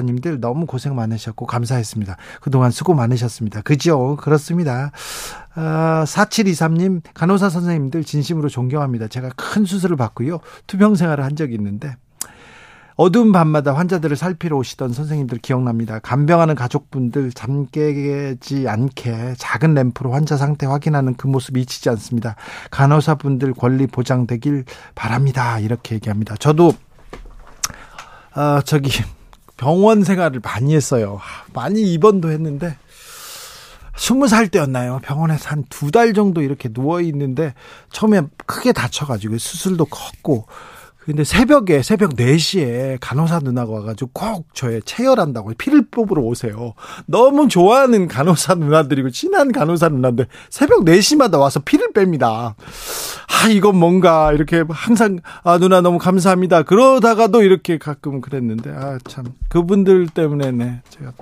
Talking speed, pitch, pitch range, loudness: 325 characters per minute, 145 Hz, 125-175 Hz, -16 LUFS